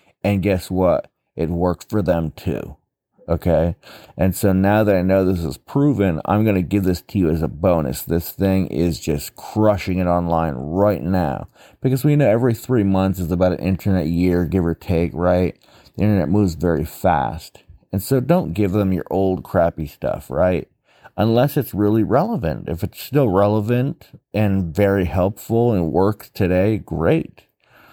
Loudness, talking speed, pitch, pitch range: -19 LUFS, 175 wpm, 95 Hz, 90-105 Hz